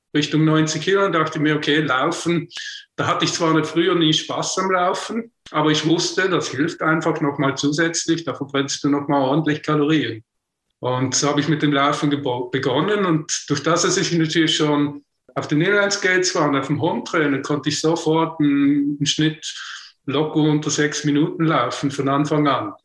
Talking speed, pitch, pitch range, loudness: 190 wpm, 155 Hz, 145-165 Hz, -19 LUFS